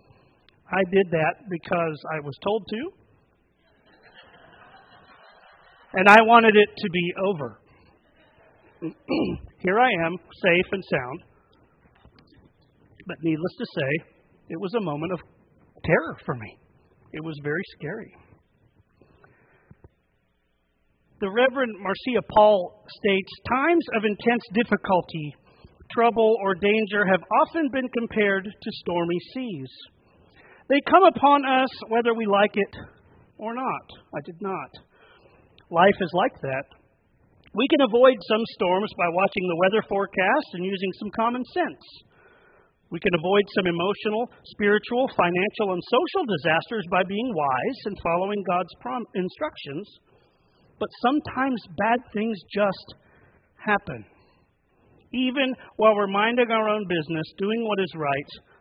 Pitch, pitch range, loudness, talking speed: 205 Hz, 180-235 Hz, -23 LUFS, 125 wpm